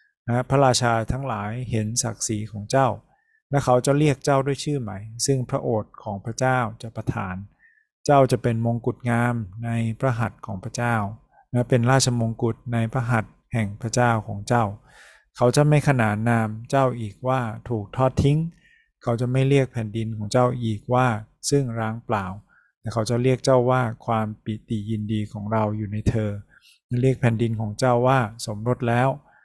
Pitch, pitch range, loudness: 120 Hz, 110-130 Hz, -23 LUFS